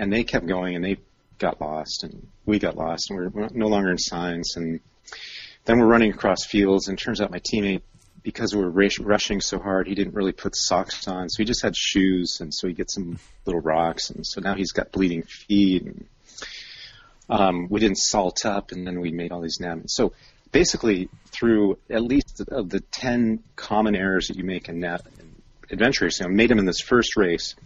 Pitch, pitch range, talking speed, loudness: 95 Hz, 90-110 Hz, 220 wpm, -23 LUFS